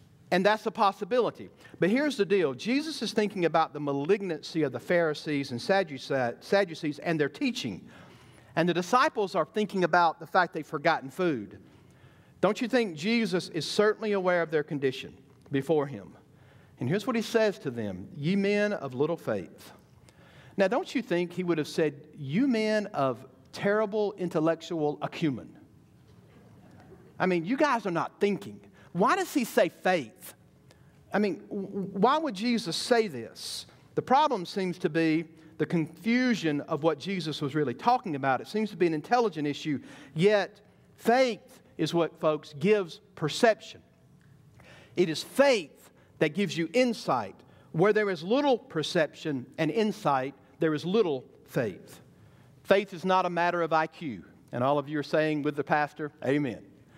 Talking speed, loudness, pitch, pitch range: 160 wpm, -28 LUFS, 170 Hz, 150-210 Hz